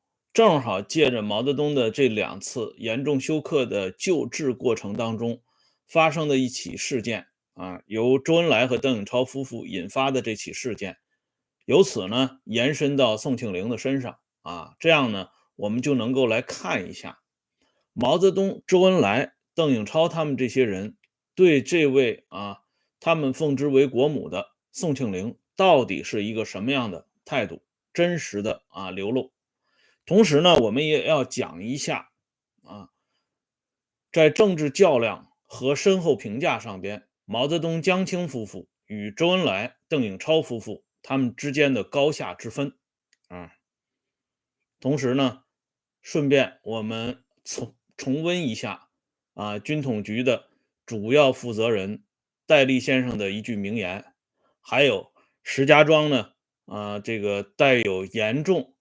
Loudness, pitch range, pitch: -23 LUFS, 110-150 Hz, 130 Hz